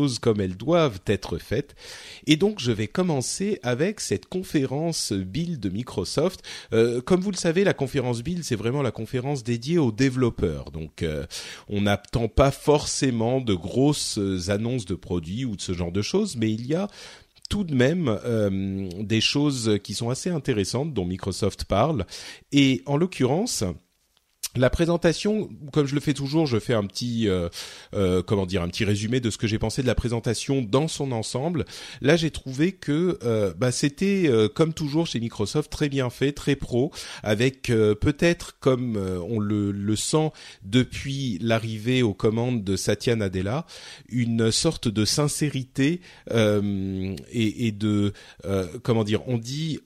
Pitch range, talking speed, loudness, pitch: 105-150 Hz, 170 wpm, -25 LUFS, 120 Hz